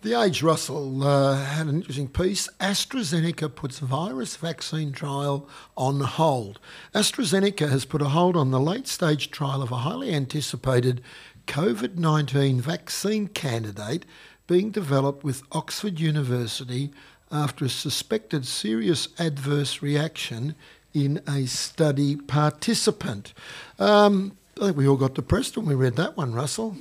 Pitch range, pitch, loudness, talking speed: 135-170 Hz, 150 Hz, -25 LUFS, 135 wpm